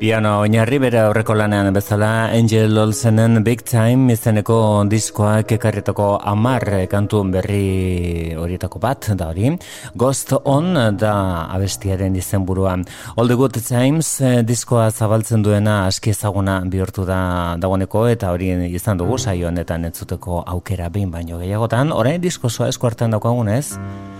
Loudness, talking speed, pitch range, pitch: -17 LUFS, 135 wpm, 95-115 Hz, 105 Hz